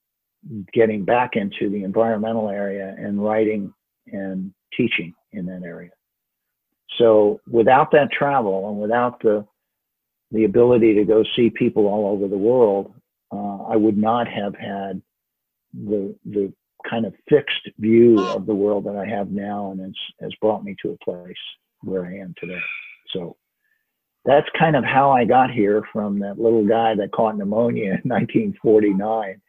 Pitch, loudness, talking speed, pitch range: 105 Hz, -20 LUFS, 165 wpm, 100-115 Hz